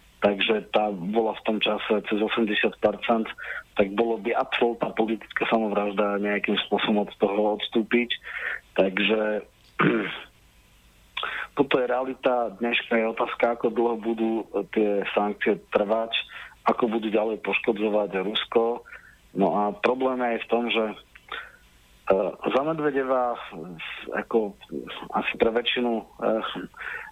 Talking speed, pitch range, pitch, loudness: 110 wpm, 105-120 Hz, 115 Hz, -25 LUFS